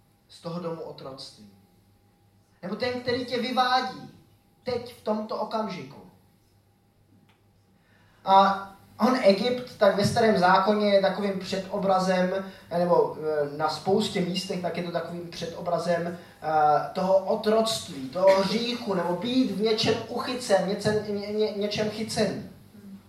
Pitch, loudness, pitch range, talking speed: 190 Hz, -25 LUFS, 155-215 Hz, 120 wpm